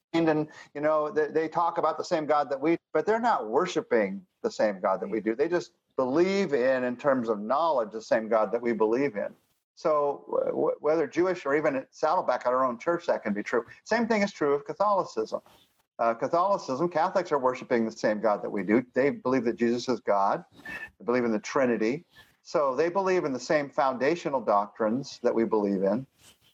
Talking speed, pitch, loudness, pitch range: 210 wpm, 150 Hz, -27 LUFS, 120-180 Hz